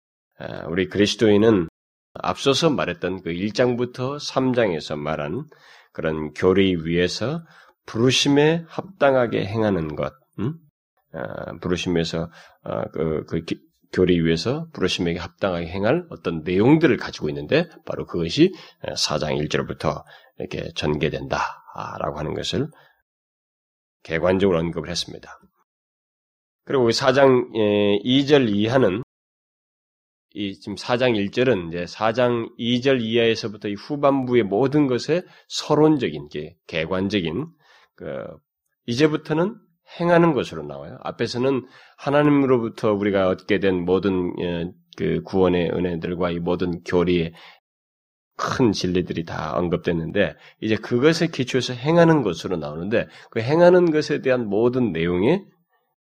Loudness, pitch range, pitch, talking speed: -21 LUFS, 90-135 Hz, 105 Hz, 265 characters per minute